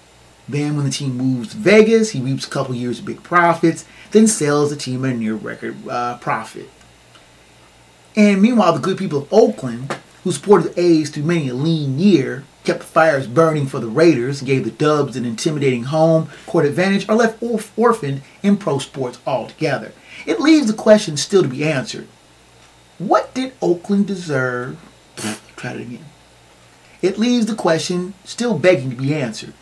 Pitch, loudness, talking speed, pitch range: 160 Hz, -17 LUFS, 180 wpm, 130-195 Hz